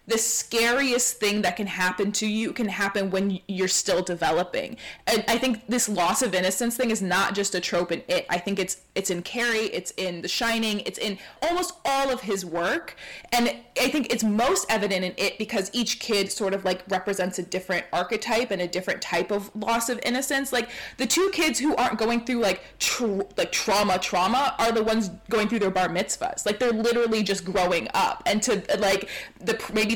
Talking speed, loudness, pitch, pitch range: 210 wpm, -25 LUFS, 210 Hz, 190-235 Hz